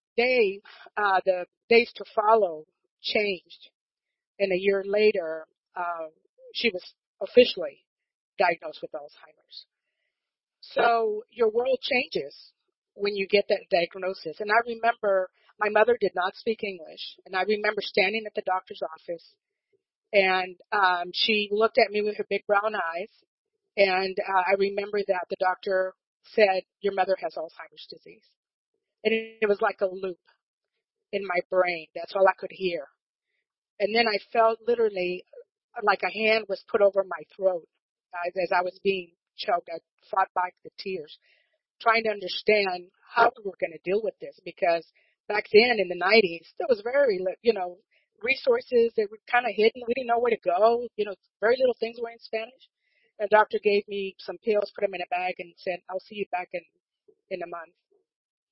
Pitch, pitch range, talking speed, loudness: 210 Hz, 185-235 Hz, 175 wpm, -26 LUFS